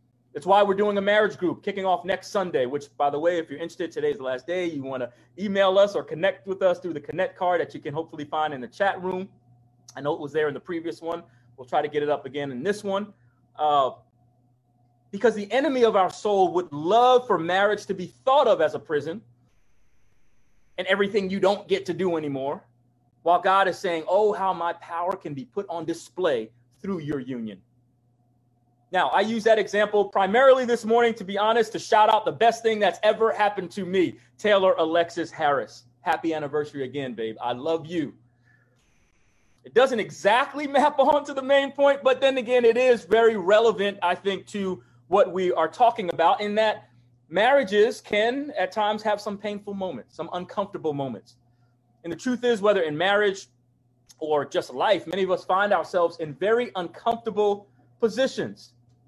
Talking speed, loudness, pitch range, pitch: 195 wpm, -24 LUFS, 135-210 Hz, 180 Hz